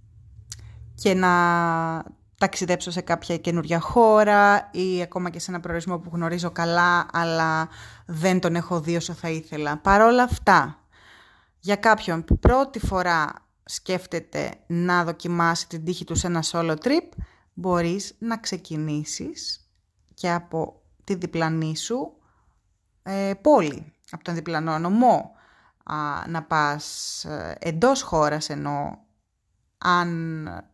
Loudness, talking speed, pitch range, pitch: -23 LUFS, 115 wpm, 160-185 Hz, 170 Hz